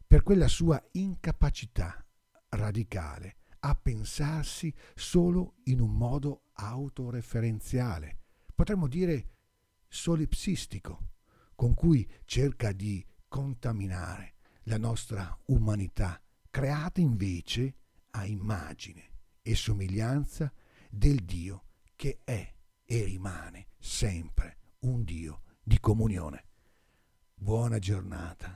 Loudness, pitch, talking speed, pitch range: -32 LUFS, 110 Hz, 90 wpm, 95-135 Hz